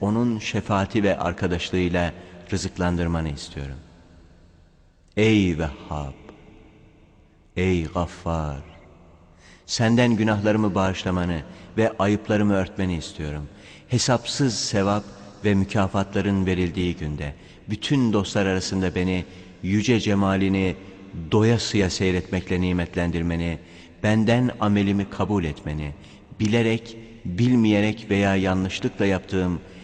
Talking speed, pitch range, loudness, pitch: 85 wpm, 85-105 Hz, -23 LUFS, 95 Hz